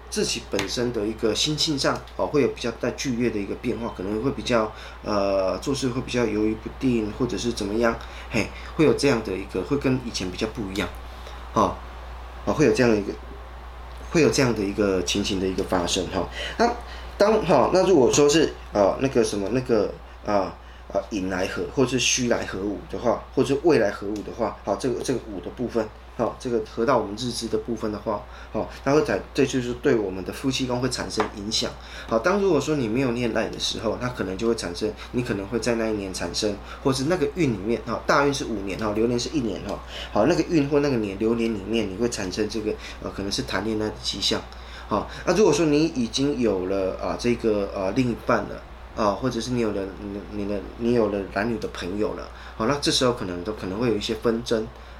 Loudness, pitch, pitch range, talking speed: -24 LUFS, 110 Hz, 95-120 Hz, 340 characters per minute